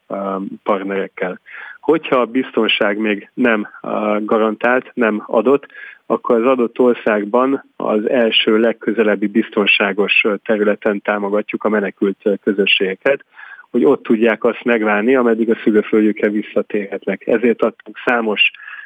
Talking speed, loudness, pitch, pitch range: 110 wpm, -16 LUFS, 110 Hz, 105-120 Hz